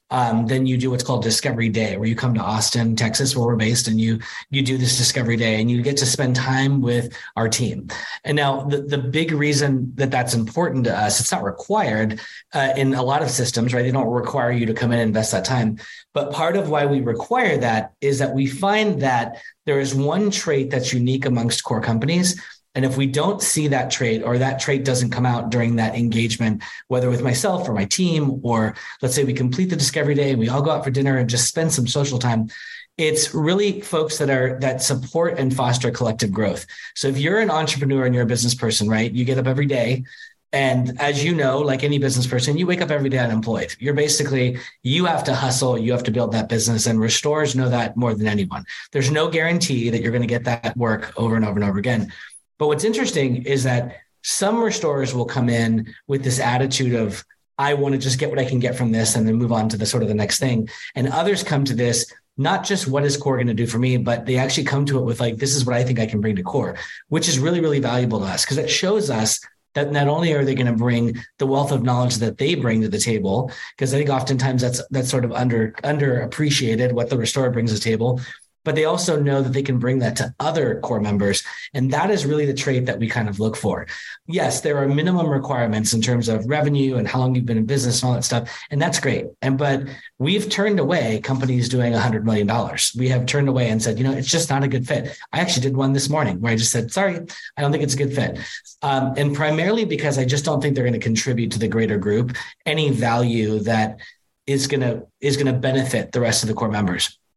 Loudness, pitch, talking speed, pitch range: -20 LUFS, 130 Hz, 250 wpm, 115-140 Hz